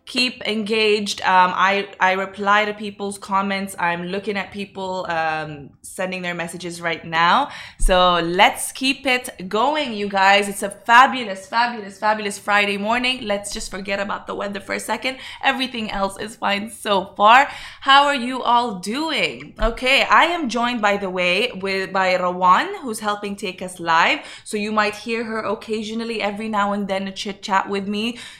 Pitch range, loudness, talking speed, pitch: 190-225 Hz, -19 LUFS, 175 wpm, 205 Hz